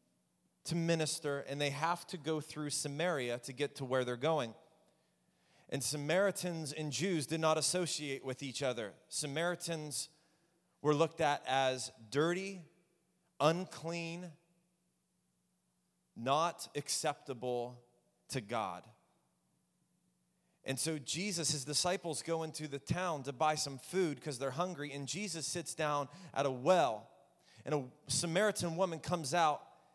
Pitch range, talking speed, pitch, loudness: 135-170 Hz, 130 wpm, 155 Hz, -36 LUFS